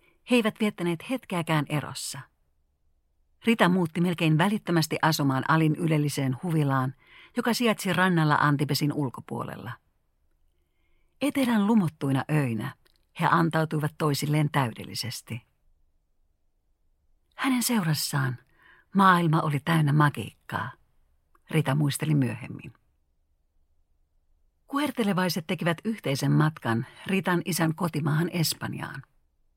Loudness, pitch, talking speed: -26 LUFS, 150 Hz, 85 wpm